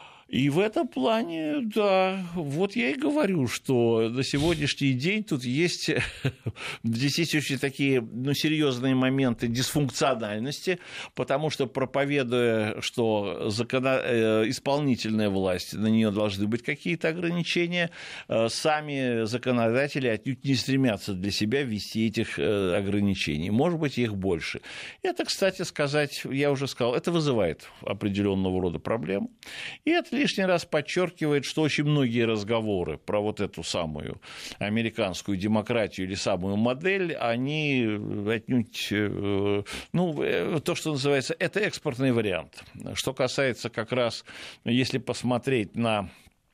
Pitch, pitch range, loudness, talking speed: 130 Hz, 110-155 Hz, -27 LUFS, 120 wpm